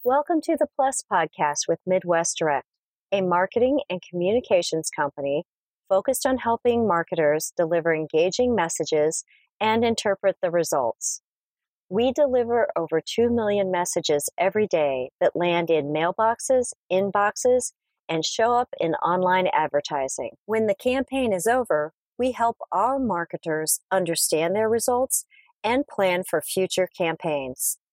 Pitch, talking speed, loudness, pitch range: 190 Hz, 130 wpm, -23 LUFS, 165-240 Hz